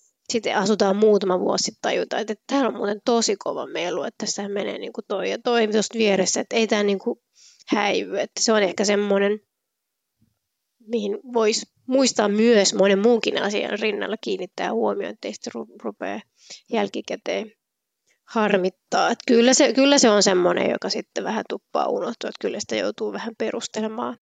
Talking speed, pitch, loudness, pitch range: 160 wpm, 220 Hz, -22 LUFS, 205-235 Hz